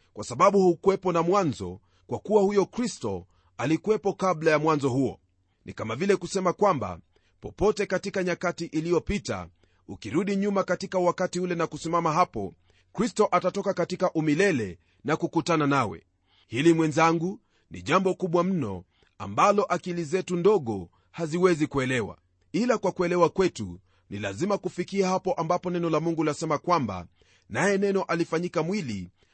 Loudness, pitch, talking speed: -26 LUFS, 165 Hz, 140 wpm